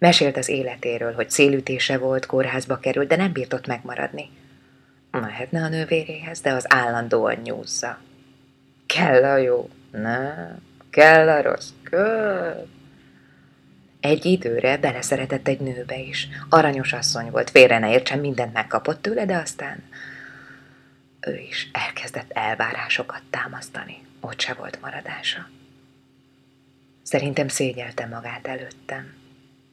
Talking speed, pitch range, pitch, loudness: 115 wpm, 130-150 Hz, 135 Hz, -21 LUFS